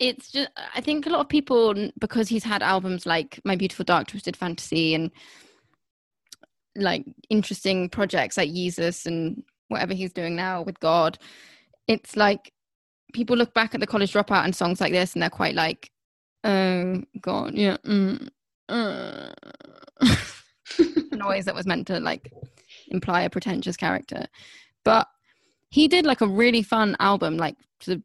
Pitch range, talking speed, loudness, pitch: 185-250 Hz, 155 wpm, -24 LUFS, 205 Hz